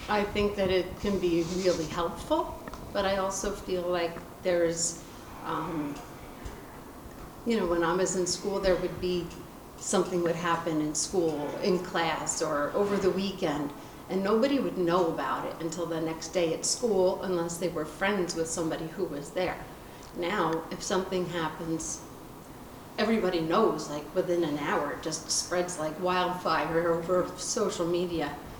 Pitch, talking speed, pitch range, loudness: 175 Hz, 155 wpm, 165-185 Hz, -29 LUFS